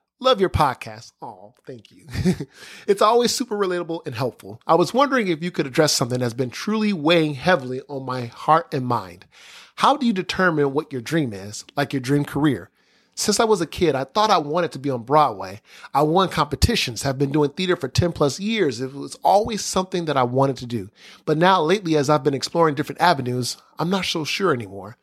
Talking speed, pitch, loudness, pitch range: 215 wpm, 150 Hz, -21 LUFS, 130-185 Hz